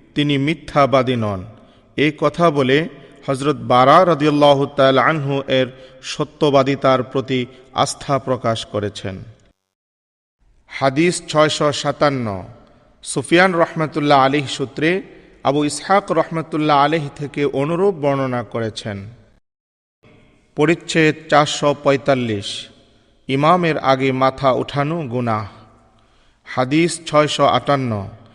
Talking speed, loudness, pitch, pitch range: 90 wpm, -17 LUFS, 140 Hz, 120-150 Hz